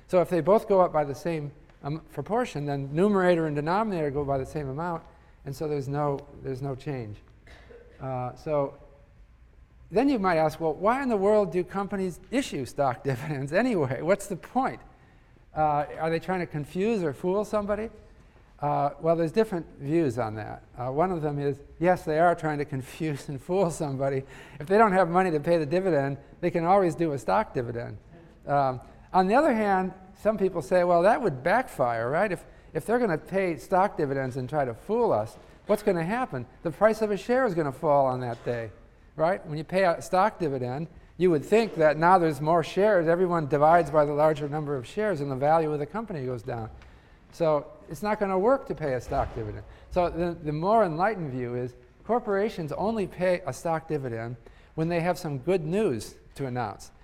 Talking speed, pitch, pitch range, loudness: 205 wpm, 160 Hz, 140-185 Hz, -27 LUFS